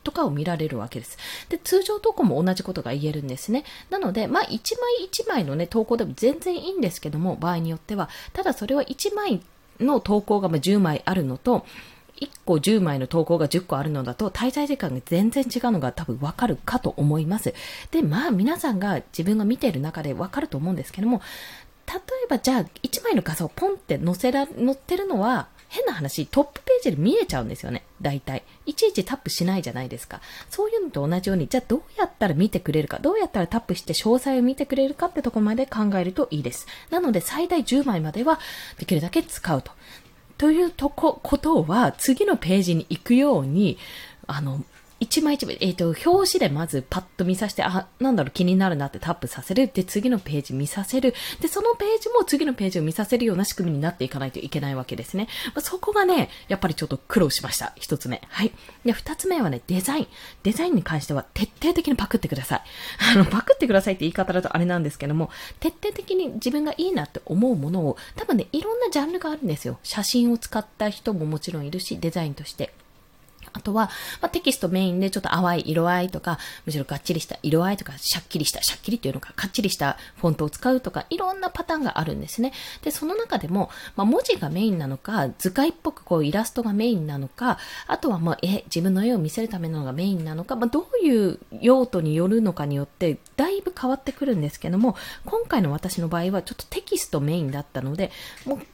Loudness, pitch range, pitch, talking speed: -24 LUFS, 165-275 Hz, 205 Hz, 445 characters per minute